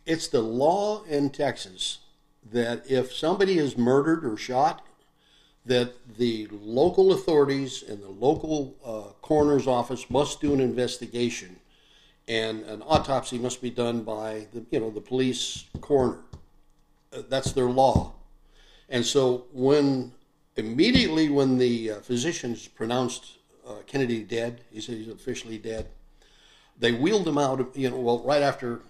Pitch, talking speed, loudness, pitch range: 125 Hz, 145 wpm, -26 LUFS, 115-140 Hz